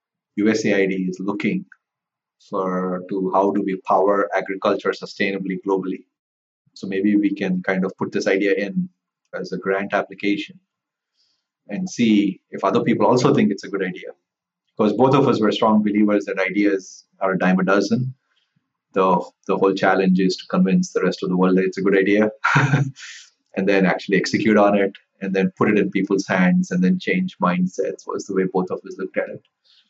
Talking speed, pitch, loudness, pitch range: 190 wpm, 100 Hz, -20 LUFS, 95-110 Hz